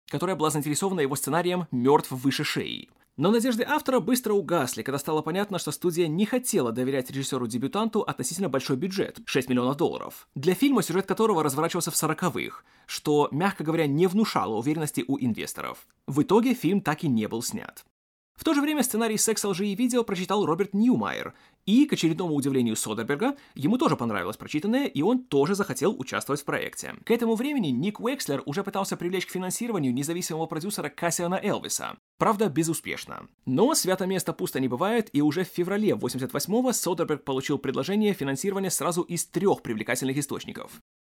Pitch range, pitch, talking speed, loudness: 145-210 Hz, 175 Hz, 170 wpm, -26 LUFS